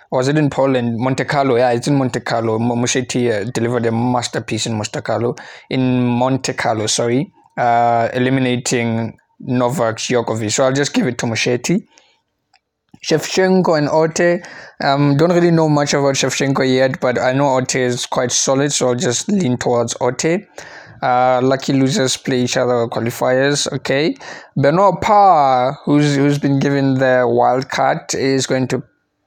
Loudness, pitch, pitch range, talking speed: -16 LUFS, 130 Hz, 120-140 Hz, 165 wpm